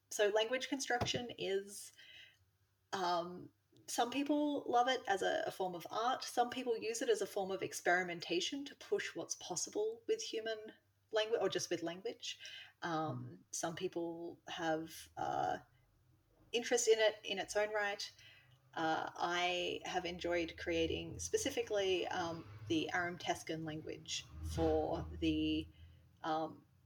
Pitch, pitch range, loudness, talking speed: 175 Hz, 155-235 Hz, -39 LUFS, 135 wpm